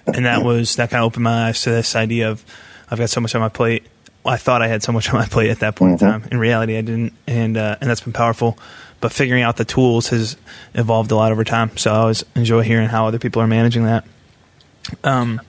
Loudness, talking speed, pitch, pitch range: -17 LUFS, 260 wpm, 115 Hz, 110-120 Hz